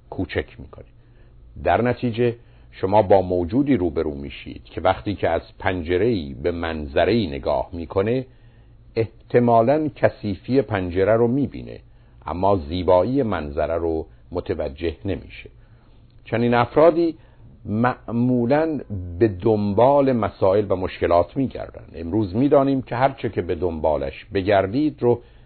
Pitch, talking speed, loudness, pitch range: 115 Hz, 110 wpm, -21 LUFS, 90-125 Hz